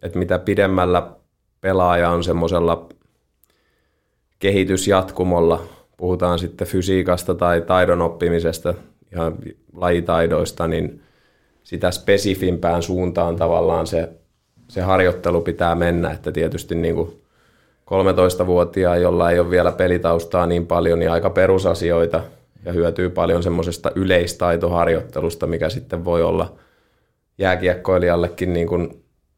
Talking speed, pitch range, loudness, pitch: 105 wpm, 85-90 Hz, -19 LUFS, 85 Hz